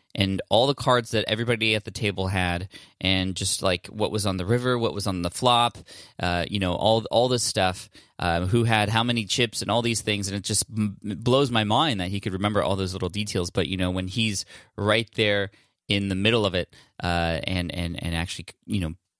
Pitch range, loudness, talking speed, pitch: 95-110 Hz, -24 LUFS, 230 wpm, 100 Hz